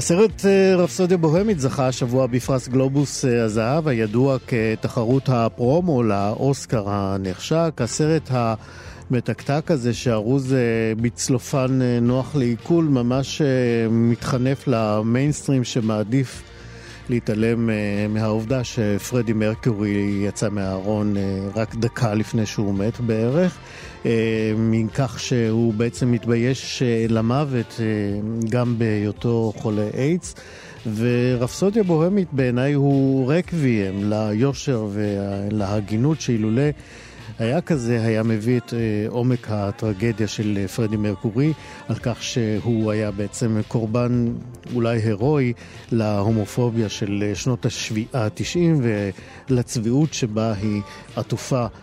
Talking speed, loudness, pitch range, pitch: 100 wpm, -21 LUFS, 110-130 Hz, 120 Hz